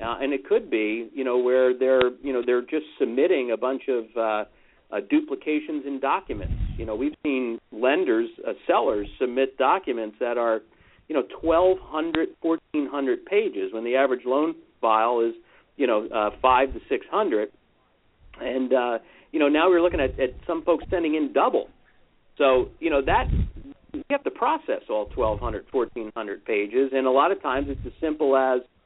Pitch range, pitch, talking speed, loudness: 125-185 Hz, 140 Hz, 185 wpm, -24 LUFS